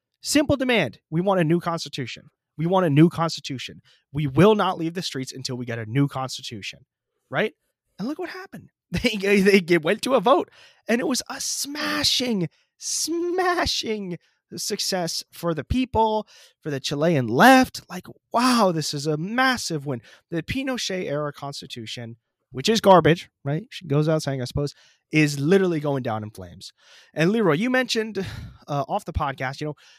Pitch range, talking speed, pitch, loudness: 140-215 Hz, 170 wpm, 165 Hz, -22 LUFS